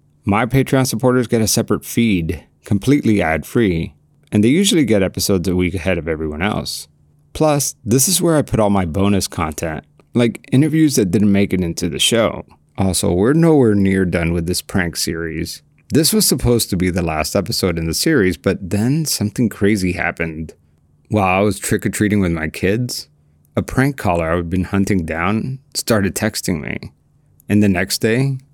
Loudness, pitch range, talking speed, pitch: -17 LUFS, 85-120 Hz, 185 wpm, 100 Hz